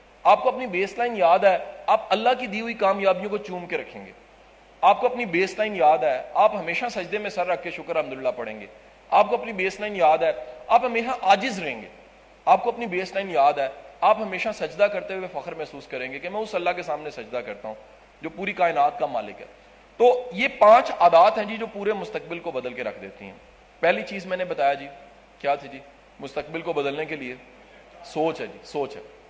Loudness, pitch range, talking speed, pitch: -23 LUFS, 155-215 Hz, 235 wpm, 185 Hz